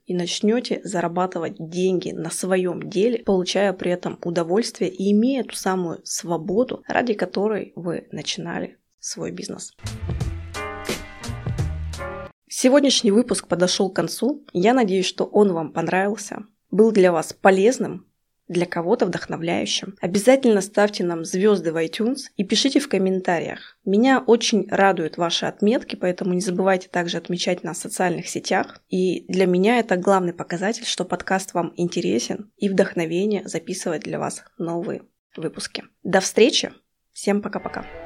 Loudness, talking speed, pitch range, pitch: -22 LUFS, 135 wpm, 175-210 Hz, 185 Hz